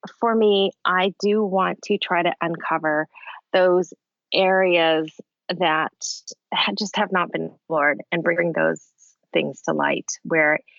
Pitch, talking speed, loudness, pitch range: 180 Hz, 135 wpm, -21 LUFS, 160-195 Hz